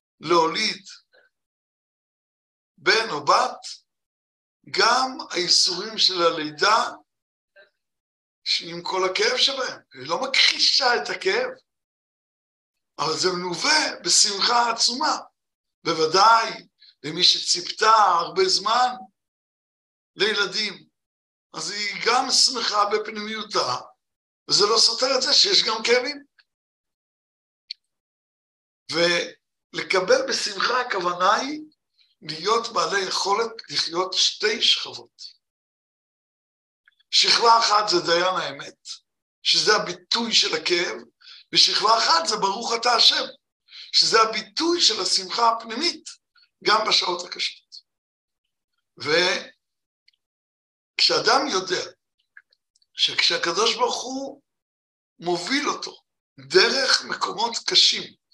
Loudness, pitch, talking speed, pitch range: -20 LUFS, 225 Hz, 85 wpm, 185-285 Hz